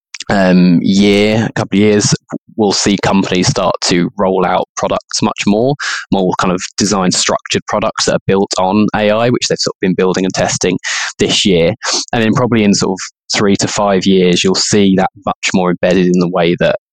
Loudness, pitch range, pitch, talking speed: -12 LUFS, 90-105 Hz, 95 Hz, 200 wpm